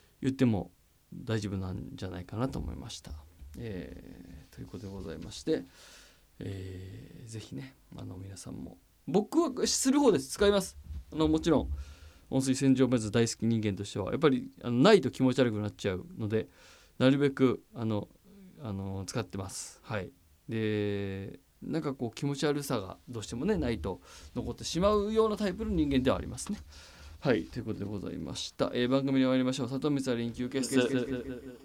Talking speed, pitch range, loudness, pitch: 360 characters per minute, 95-135 Hz, -31 LUFS, 120 Hz